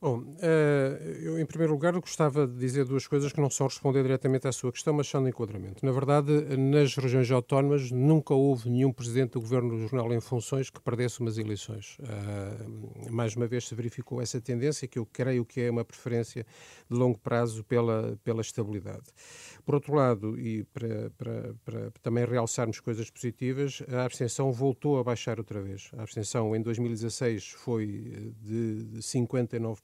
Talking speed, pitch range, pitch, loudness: 170 wpm, 115-135 Hz, 125 Hz, -30 LUFS